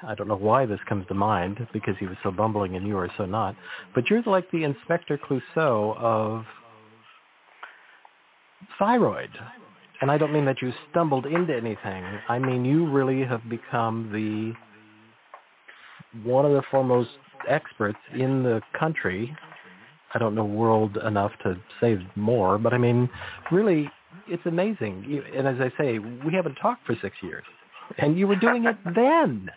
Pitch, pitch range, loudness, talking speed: 120 Hz, 110-145 Hz, -25 LUFS, 160 wpm